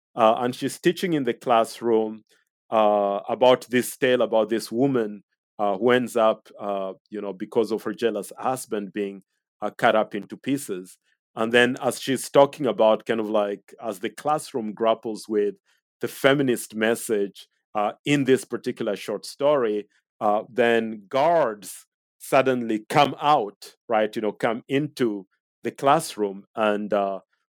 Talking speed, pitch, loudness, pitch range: 155 wpm, 110 Hz, -24 LUFS, 105-125 Hz